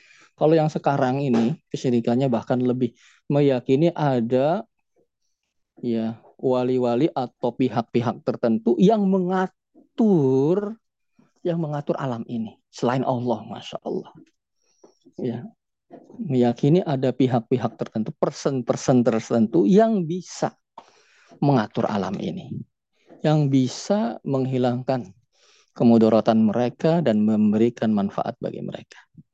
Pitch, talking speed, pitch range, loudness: 130 Hz, 95 wpm, 120-155 Hz, -22 LUFS